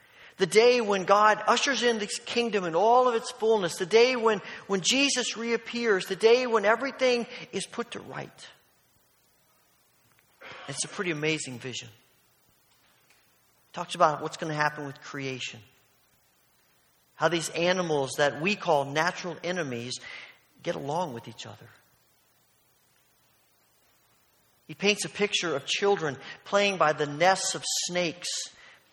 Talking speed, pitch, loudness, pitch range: 135 wpm, 180 Hz, -26 LUFS, 145-220 Hz